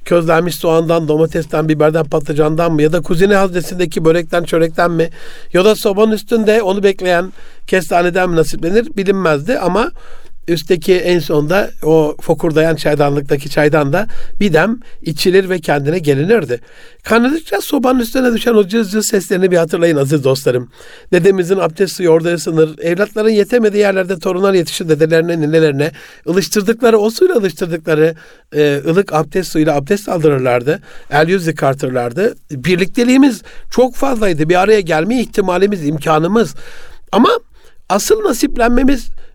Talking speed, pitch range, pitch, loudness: 130 wpm, 160-205 Hz, 180 Hz, -13 LUFS